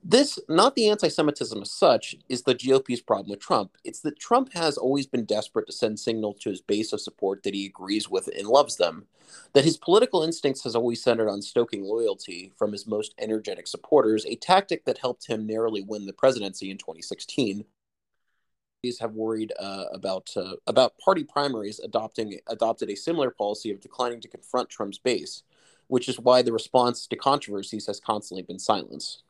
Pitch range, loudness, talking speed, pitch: 105-150 Hz, -26 LUFS, 190 wpm, 120 Hz